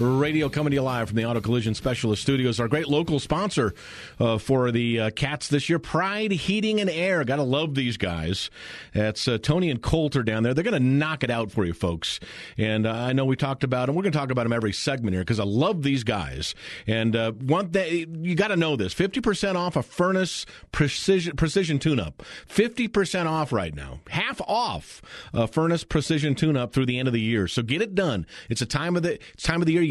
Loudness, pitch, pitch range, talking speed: -25 LUFS, 140 Hz, 115-165 Hz, 235 wpm